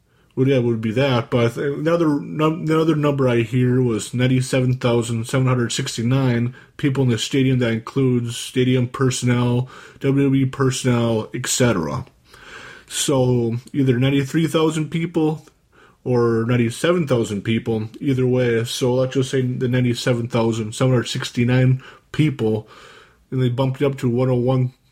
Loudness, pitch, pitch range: -20 LUFS, 130 Hz, 120-135 Hz